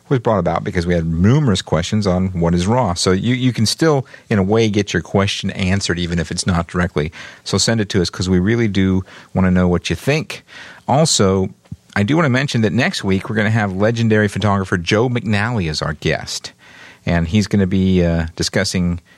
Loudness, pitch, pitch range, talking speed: -17 LUFS, 100 Hz, 90-110 Hz, 220 wpm